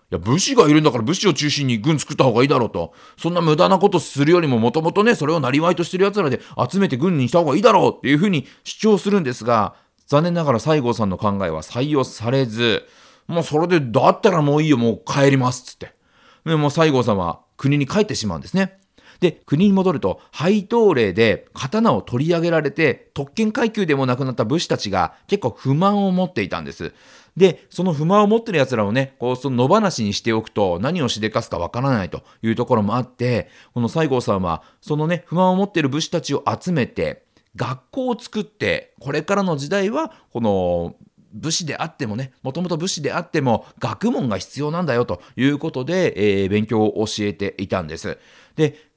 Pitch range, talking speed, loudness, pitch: 120-180 Hz, 415 characters per minute, -19 LUFS, 150 Hz